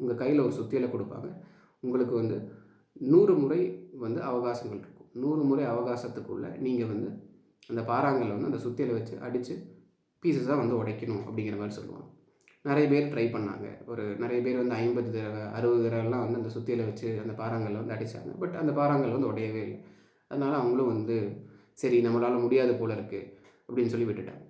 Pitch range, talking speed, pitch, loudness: 110-130 Hz, 165 wpm, 120 Hz, -30 LUFS